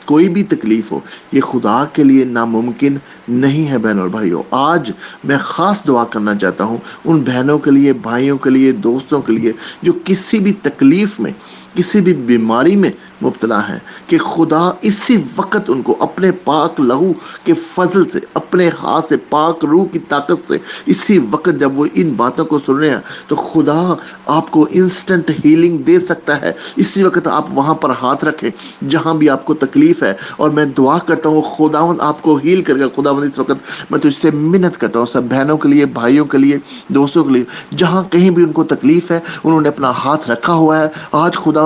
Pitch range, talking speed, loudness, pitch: 135-175 Hz, 205 wpm, -13 LUFS, 155 Hz